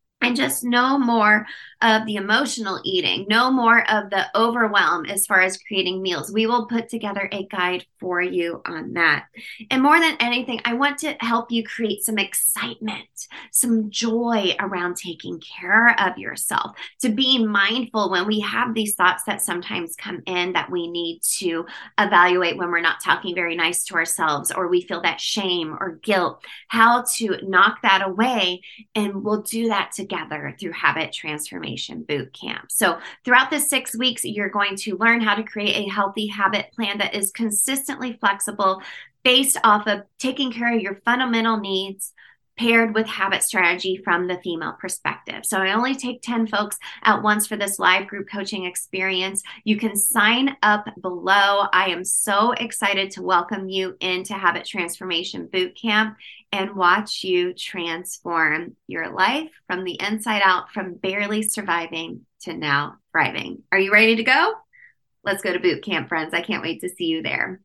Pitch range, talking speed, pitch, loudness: 185-230 Hz, 170 wpm, 205 Hz, -21 LUFS